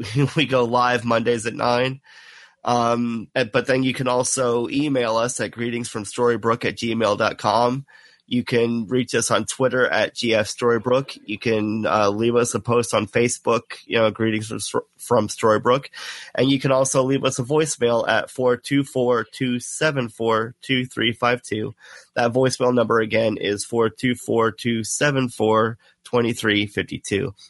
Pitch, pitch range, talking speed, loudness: 120 Hz, 115-130 Hz, 135 wpm, -21 LUFS